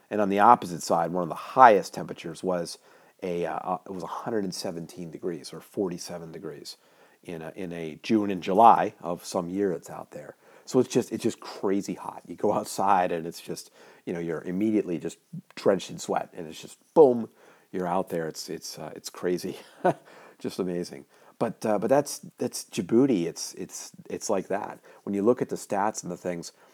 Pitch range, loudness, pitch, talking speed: 85-105 Hz, -27 LUFS, 90 Hz, 200 wpm